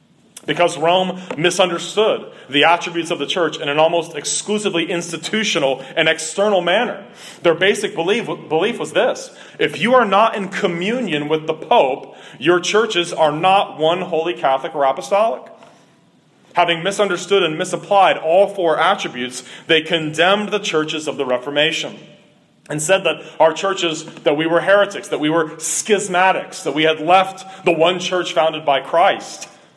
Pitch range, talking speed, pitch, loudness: 160-190 Hz, 155 wpm, 170 Hz, -17 LUFS